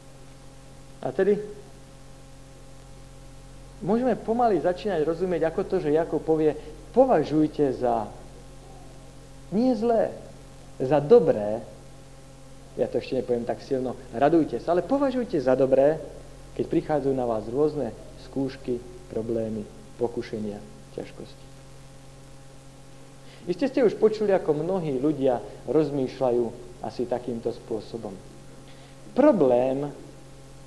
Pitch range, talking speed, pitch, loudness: 130-155 Hz, 100 wpm, 135 Hz, -25 LUFS